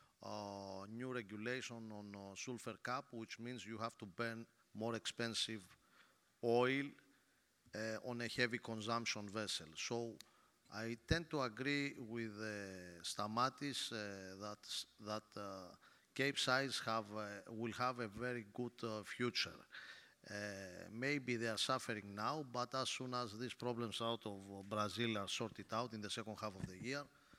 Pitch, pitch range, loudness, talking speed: 115 Hz, 105-125 Hz, -44 LUFS, 150 wpm